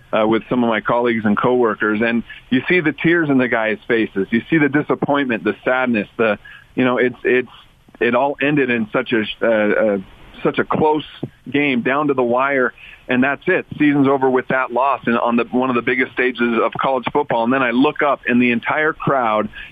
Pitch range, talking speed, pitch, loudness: 115-140 Hz, 220 wpm, 125 Hz, -17 LUFS